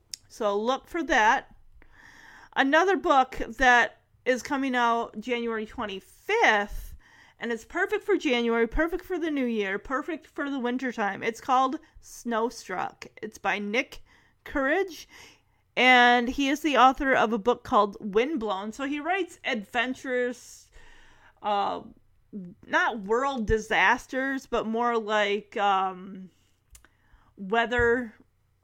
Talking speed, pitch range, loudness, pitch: 115 wpm, 220-280 Hz, -26 LUFS, 245 Hz